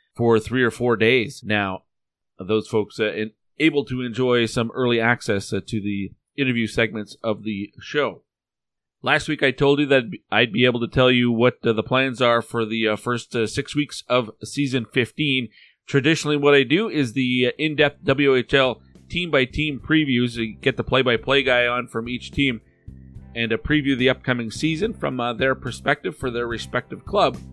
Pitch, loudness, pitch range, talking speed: 125 Hz, -21 LUFS, 115-135 Hz, 200 wpm